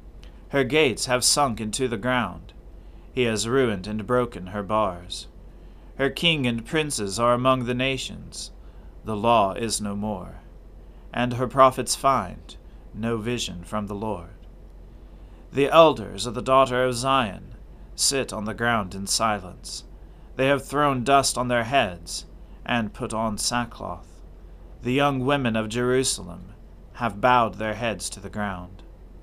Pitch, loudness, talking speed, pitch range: 110 Hz, -23 LUFS, 150 wpm, 90-125 Hz